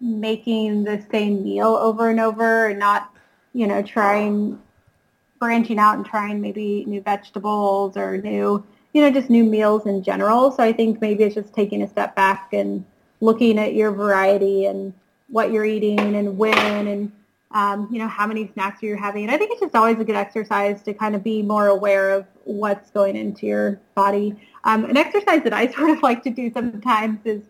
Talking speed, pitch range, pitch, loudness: 200 wpm, 200-225 Hz, 210 Hz, -20 LUFS